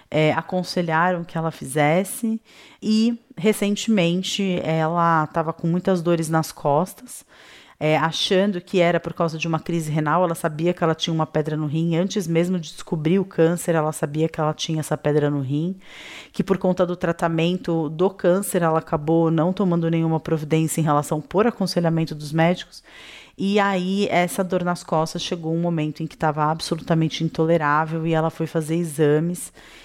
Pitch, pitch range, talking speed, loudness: 165 Hz, 160-180 Hz, 175 wpm, -22 LUFS